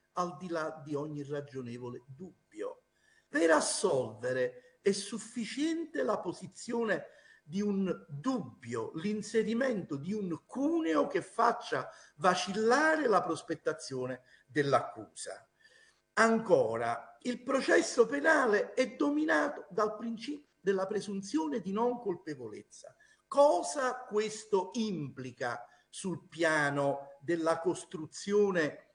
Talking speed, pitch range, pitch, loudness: 95 wpm, 160-260 Hz, 205 Hz, -32 LUFS